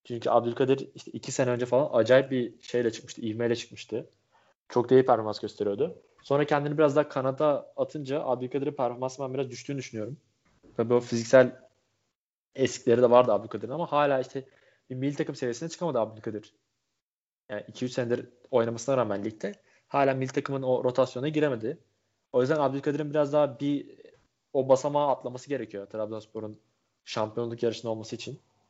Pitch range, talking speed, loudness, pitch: 120-140 Hz, 150 wpm, -28 LUFS, 130 Hz